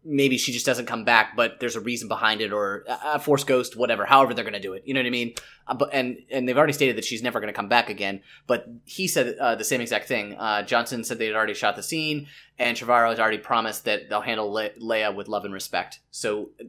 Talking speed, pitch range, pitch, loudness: 275 wpm, 110-130 Hz, 115 Hz, -24 LUFS